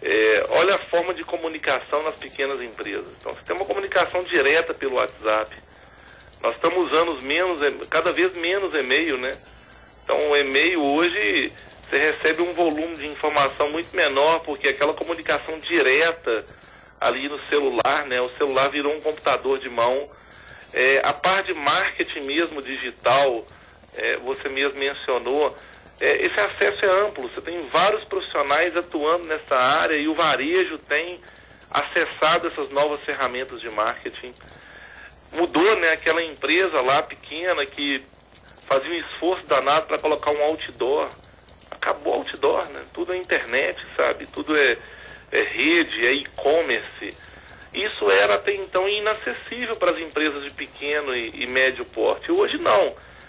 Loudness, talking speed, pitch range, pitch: -22 LUFS, 145 wpm, 145-210 Hz, 165 Hz